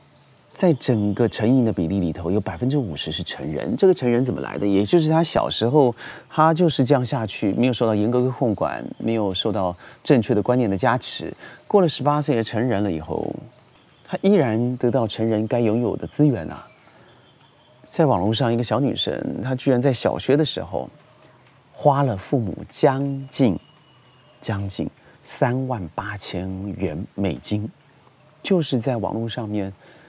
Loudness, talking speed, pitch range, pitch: -22 LUFS, 255 characters per minute, 105-140 Hz, 125 Hz